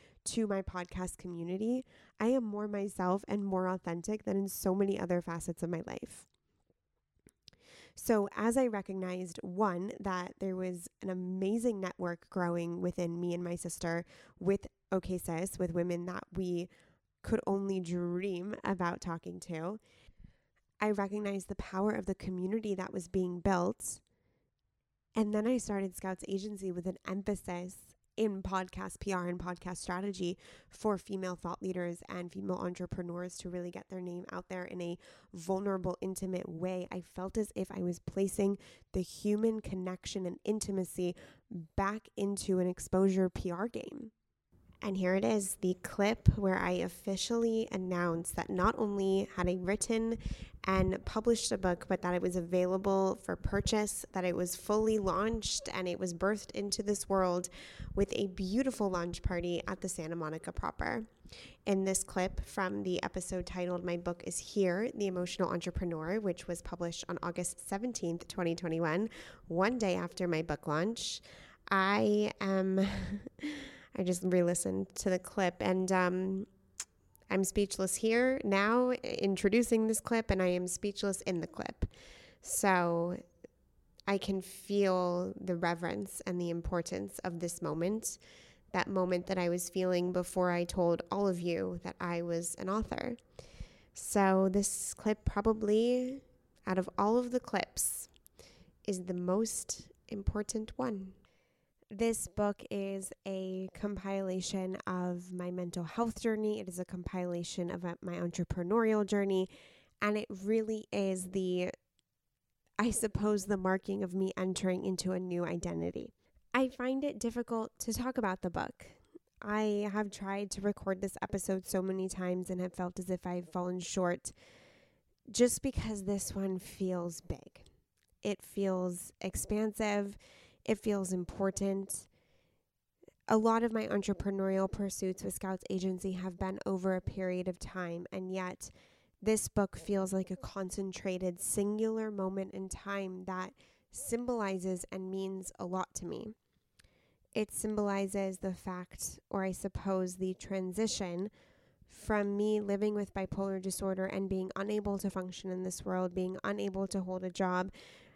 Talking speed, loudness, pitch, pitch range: 150 wpm, -35 LUFS, 190 Hz, 180-205 Hz